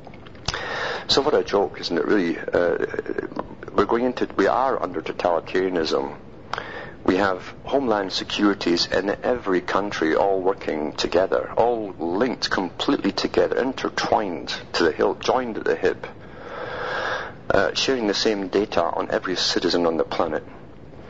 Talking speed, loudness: 135 wpm, -23 LUFS